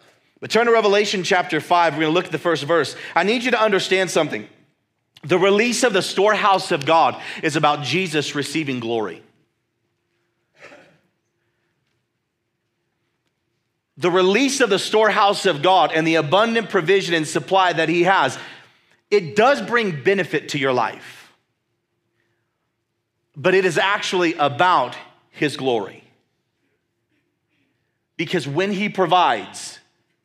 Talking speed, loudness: 130 wpm, -18 LUFS